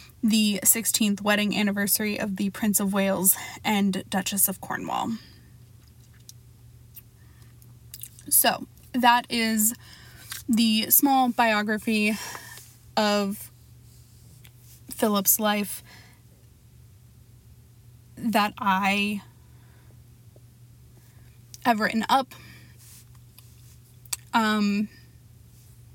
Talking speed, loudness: 65 wpm, -23 LUFS